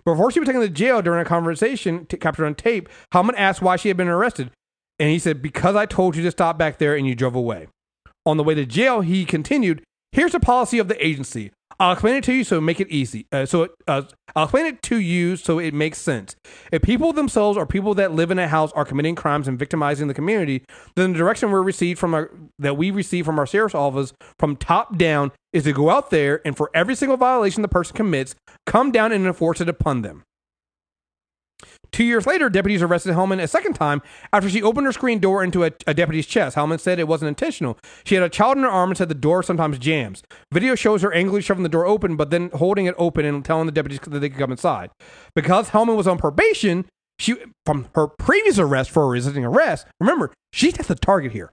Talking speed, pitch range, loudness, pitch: 240 wpm, 150-200 Hz, -20 LUFS, 170 Hz